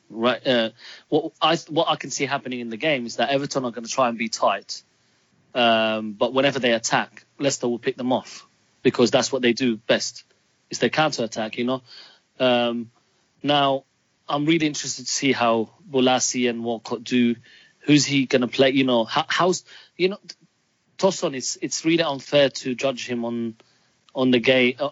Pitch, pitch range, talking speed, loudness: 130 Hz, 120-140 Hz, 195 wpm, -22 LUFS